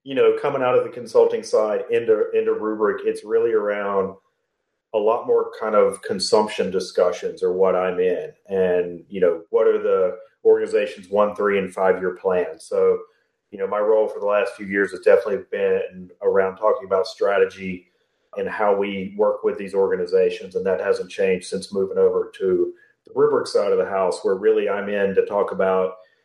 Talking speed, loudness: 190 wpm, -21 LUFS